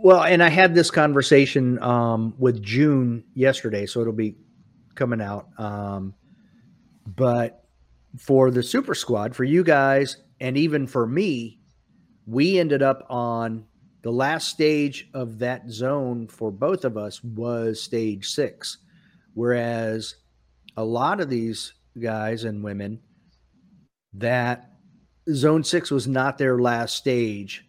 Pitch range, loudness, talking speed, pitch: 110-135 Hz, -22 LUFS, 130 wpm, 120 Hz